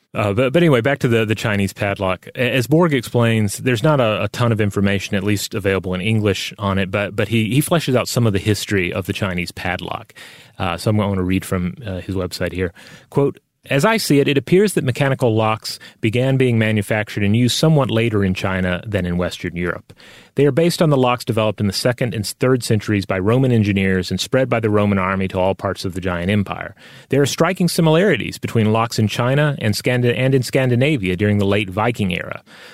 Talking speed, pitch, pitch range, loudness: 225 wpm, 110 Hz, 100-130 Hz, -18 LUFS